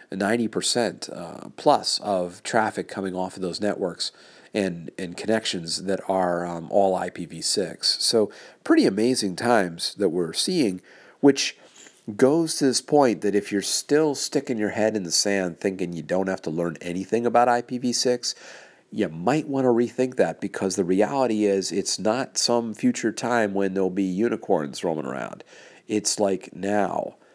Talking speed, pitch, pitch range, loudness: 160 wpm, 105 Hz, 95-120 Hz, -24 LUFS